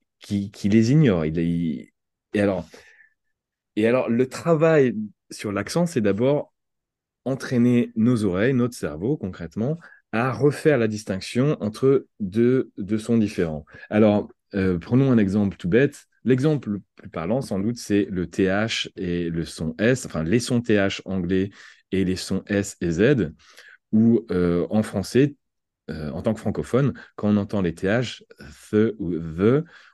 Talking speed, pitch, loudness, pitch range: 155 wpm, 105 Hz, -23 LUFS, 95-125 Hz